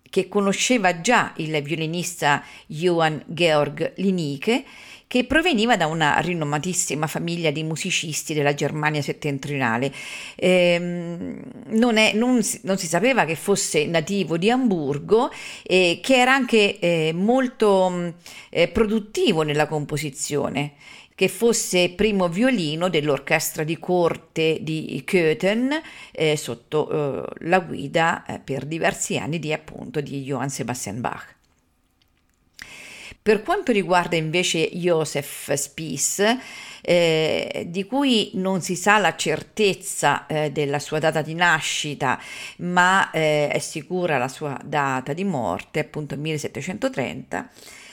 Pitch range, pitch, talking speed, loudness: 150-195 Hz, 165 Hz, 120 wpm, -22 LUFS